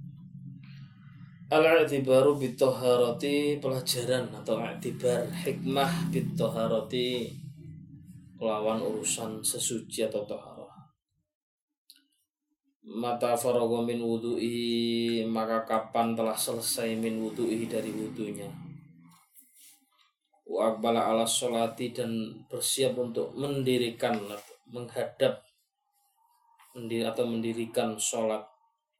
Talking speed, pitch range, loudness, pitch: 70 wpm, 115-155 Hz, -29 LUFS, 125 Hz